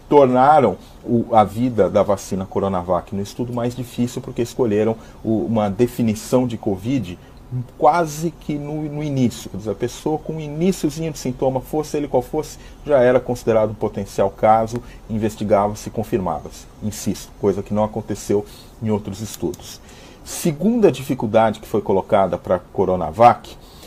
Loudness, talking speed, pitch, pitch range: -20 LUFS, 150 wpm, 120 Hz, 105-135 Hz